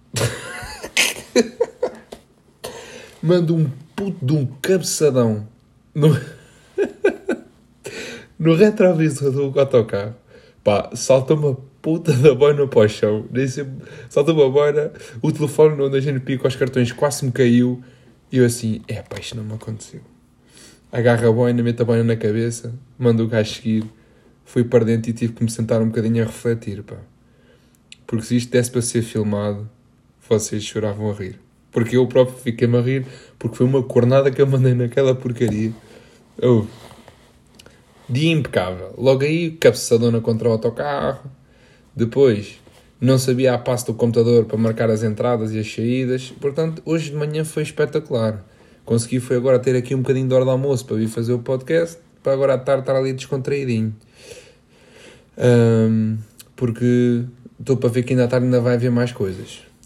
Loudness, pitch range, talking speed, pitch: -19 LUFS, 115-140 Hz, 160 wpm, 125 Hz